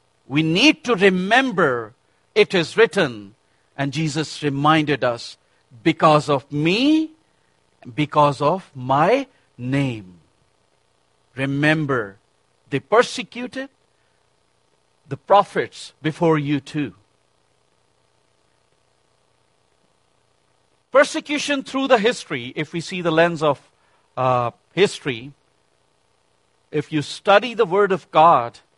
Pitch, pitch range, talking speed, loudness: 150 Hz, 130-195 Hz, 95 wpm, -19 LUFS